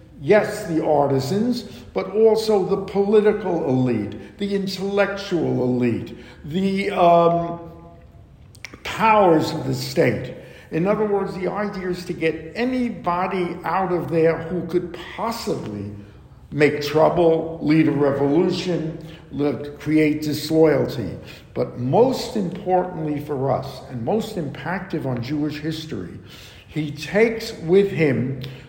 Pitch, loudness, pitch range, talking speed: 165 Hz, -21 LUFS, 145-195 Hz, 115 wpm